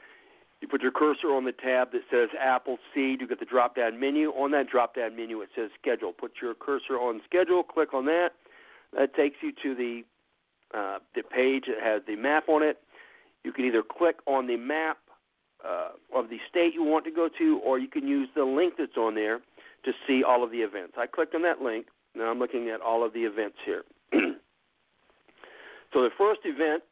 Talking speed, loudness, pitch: 210 wpm, -28 LUFS, 145 Hz